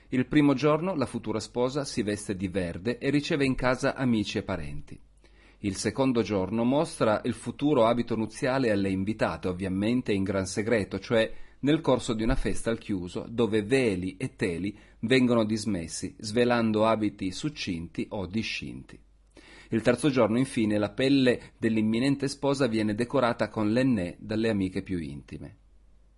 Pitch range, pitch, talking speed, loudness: 100-125 Hz, 110 Hz, 150 wpm, -27 LUFS